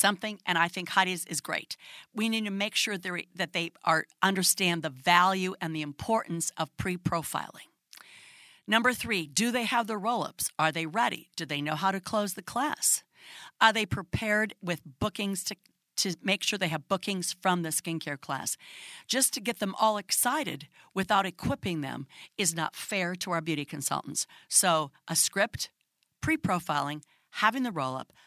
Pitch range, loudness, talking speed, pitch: 160-215 Hz, -29 LUFS, 180 wpm, 185 Hz